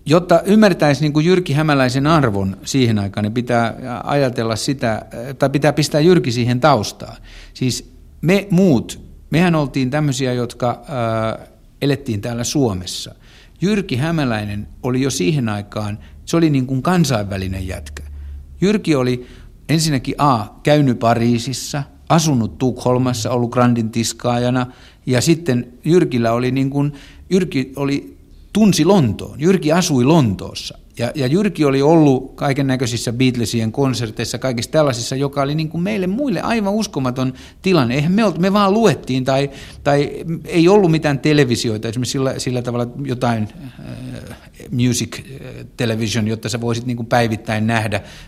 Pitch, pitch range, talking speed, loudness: 130 Hz, 115-150 Hz, 140 wpm, -17 LUFS